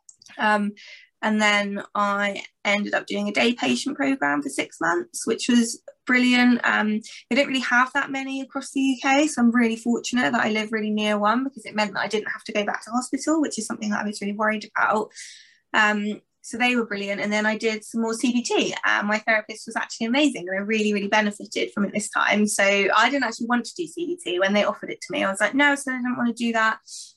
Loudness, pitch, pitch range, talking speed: -23 LUFS, 225 Hz, 210-255 Hz, 245 wpm